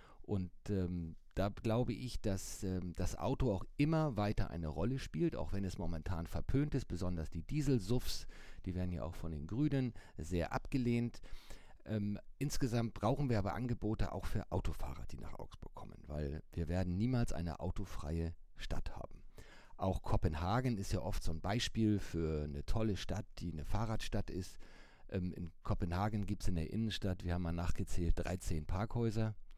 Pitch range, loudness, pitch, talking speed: 85-110 Hz, -40 LUFS, 95 Hz, 170 wpm